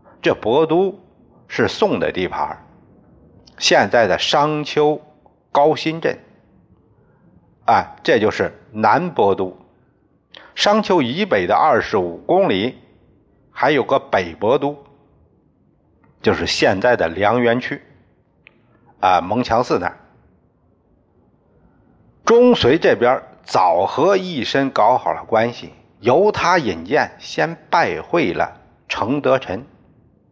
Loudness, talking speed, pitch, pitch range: -17 LUFS, 150 characters per minute, 140 Hz, 120-155 Hz